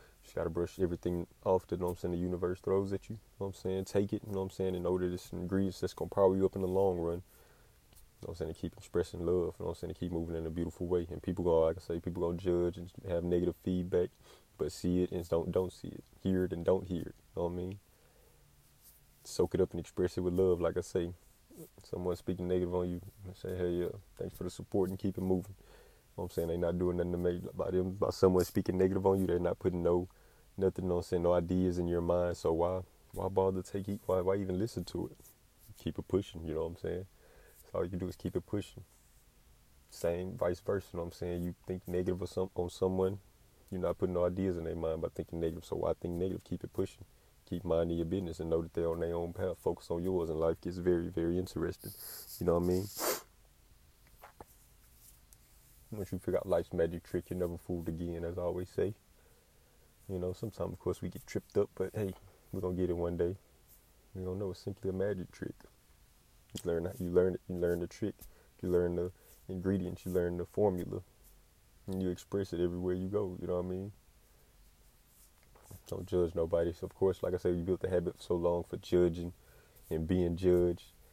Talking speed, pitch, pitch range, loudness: 250 wpm, 90 Hz, 85-95 Hz, -35 LUFS